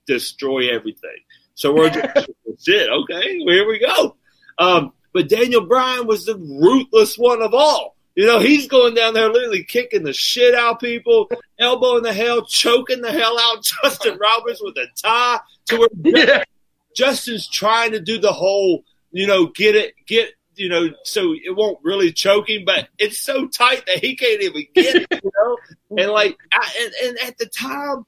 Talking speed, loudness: 185 wpm, -16 LUFS